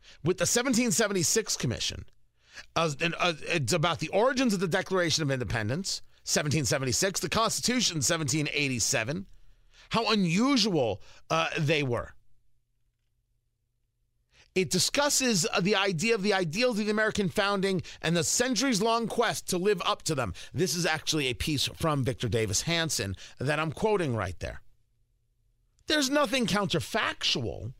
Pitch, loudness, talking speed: 165 Hz, -27 LUFS, 140 wpm